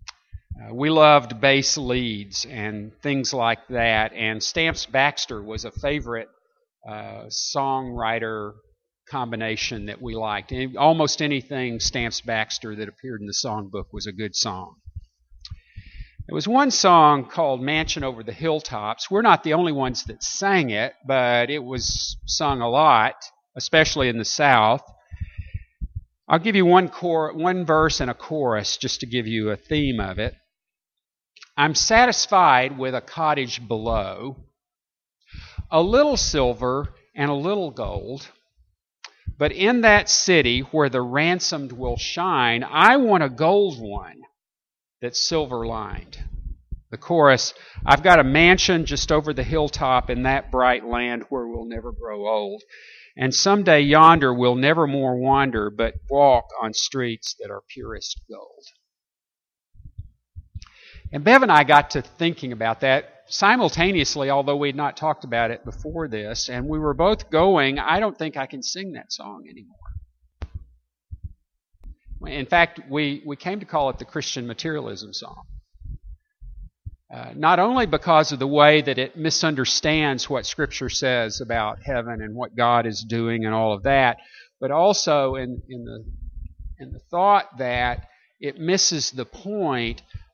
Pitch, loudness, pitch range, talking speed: 130 Hz, -20 LUFS, 110-155 Hz, 150 wpm